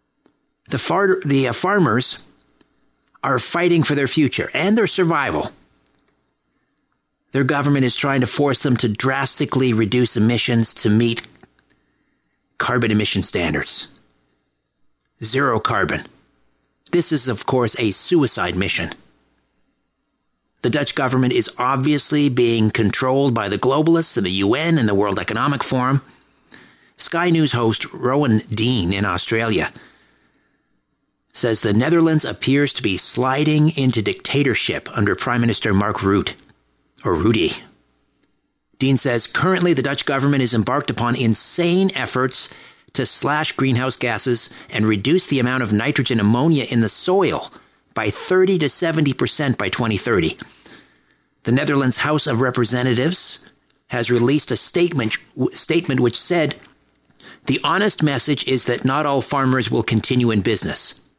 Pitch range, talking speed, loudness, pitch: 115-145 Hz, 130 wpm, -18 LUFS, 130 Hz